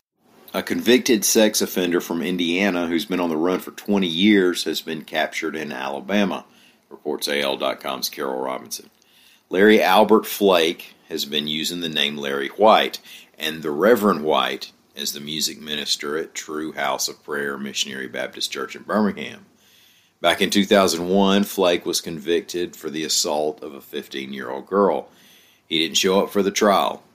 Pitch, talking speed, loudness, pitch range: 85 Hz, 160 wpm, -21 LUFS, 75-100 Hz